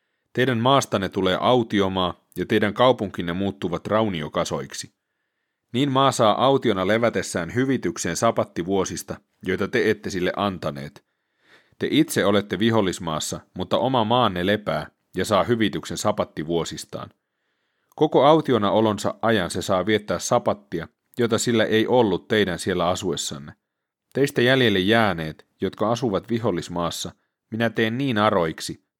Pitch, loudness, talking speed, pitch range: 110 Hz, -22 LUFS, 120 wpm, 90-120 Hz